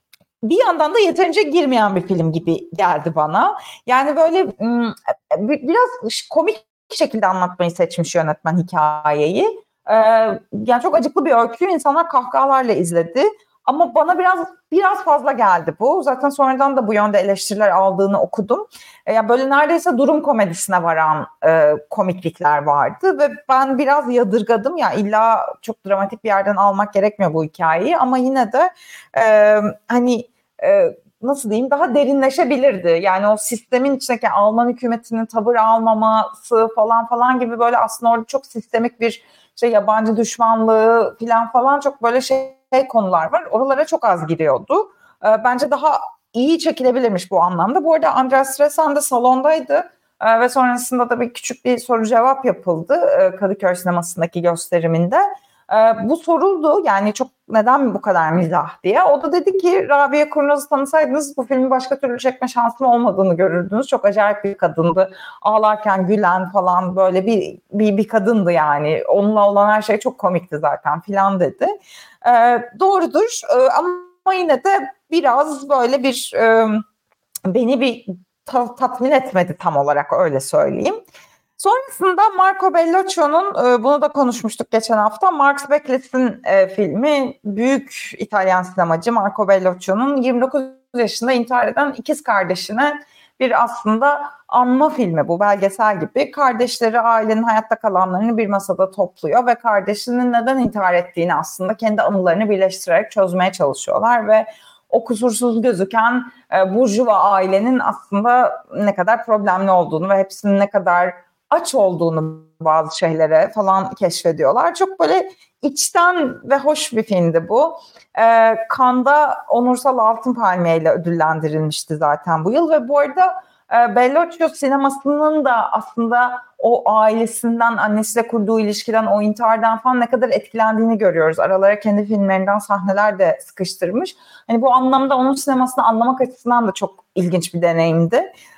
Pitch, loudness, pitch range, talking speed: 235 Hz, -16 LUFS, 195-280 Hz, 140 wpm